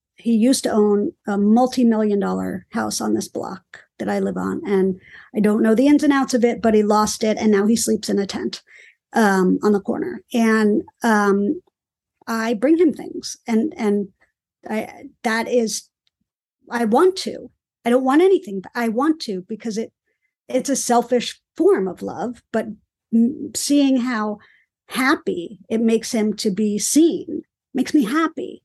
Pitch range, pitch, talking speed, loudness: 210-265 Hz, 230 Hz, 175 wpm, -20 LUFS